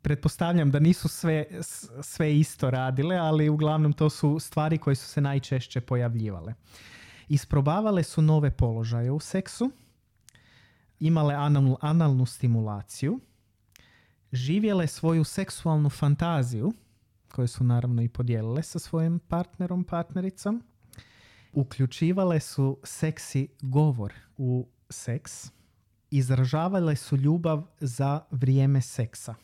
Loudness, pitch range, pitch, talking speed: -27 LUFS, 120-155 Hz, 140 Hz, 105 wpm